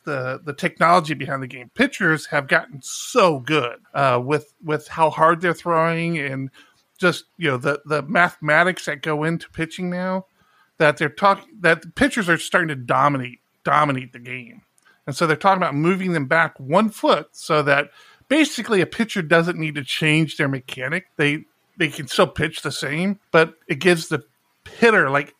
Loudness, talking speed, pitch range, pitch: -20 LUFS, 180 wpm, 145-175 Hz, 160 Hz